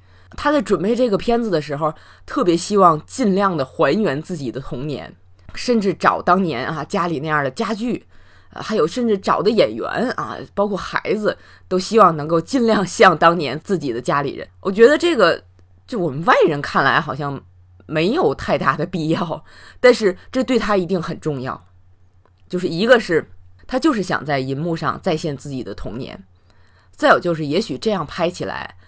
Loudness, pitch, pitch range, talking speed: -18 LUFS, 165 Hz, 130-200 Hz, 270 characters per minute